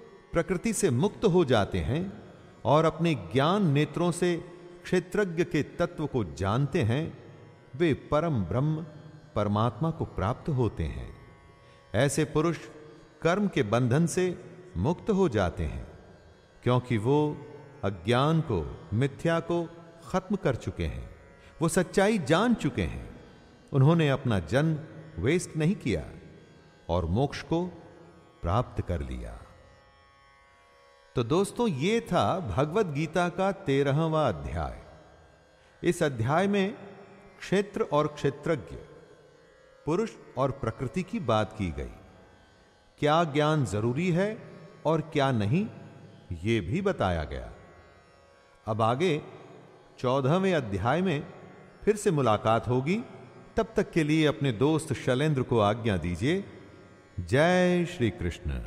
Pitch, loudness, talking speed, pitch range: 145 Hz, -28 LUFS, 120 wpm, 105-175 Hz